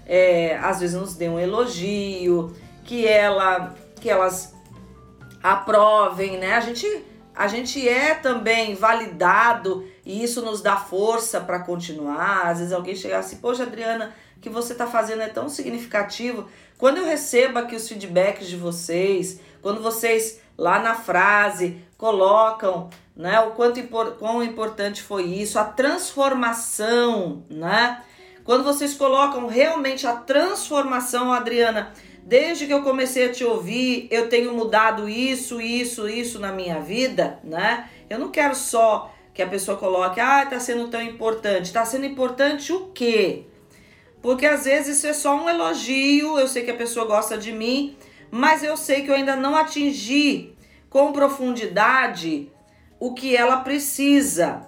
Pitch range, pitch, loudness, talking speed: 195-260 Hz, 230 Hz, -21 LUFS, 155 wpm